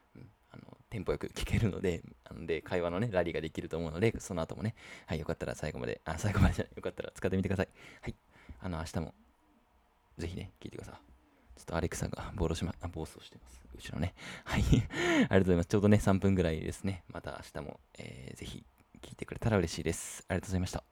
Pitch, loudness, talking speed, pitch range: 90 Hz, -34 LUFS, 475 characters per minute, 80-100 Hz